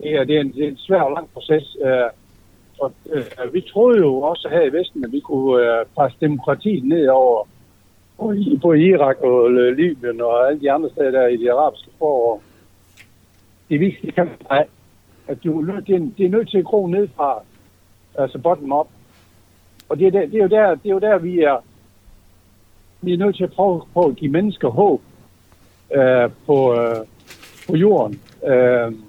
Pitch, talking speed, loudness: 135 Hz, 190 wpm, -18 LUFS